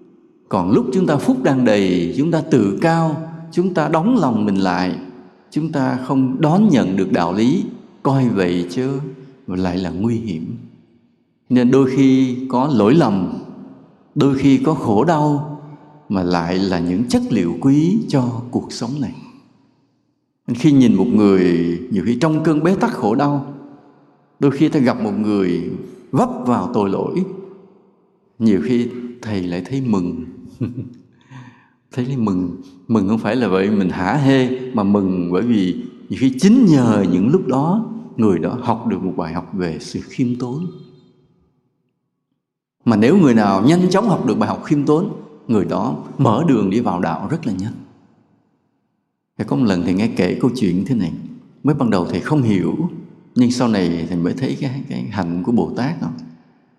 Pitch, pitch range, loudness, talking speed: 135 Hz, 105-165 Hz, -17 LUFS, 180 wpm